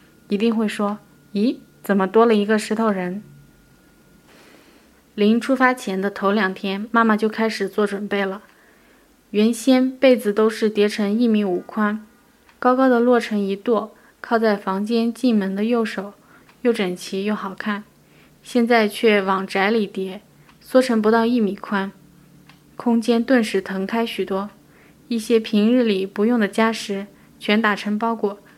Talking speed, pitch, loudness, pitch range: 215 characters per minute, 215 Hz, -20 LUFS, 200-230 Hz